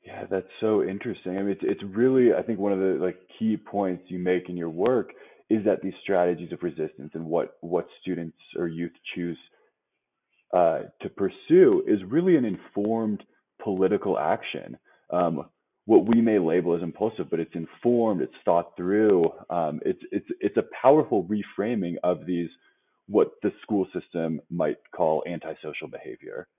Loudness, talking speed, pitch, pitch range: -26 LUFS, 165 wpm, 90 Hz, 85-105 Hz